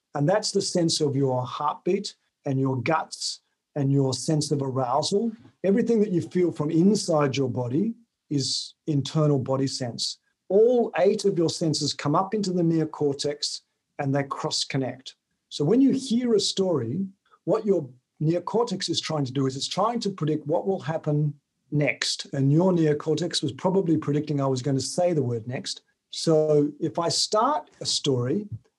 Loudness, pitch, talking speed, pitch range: -25 LUFS, 155 Hz, 175 wpm, 140-185 Hz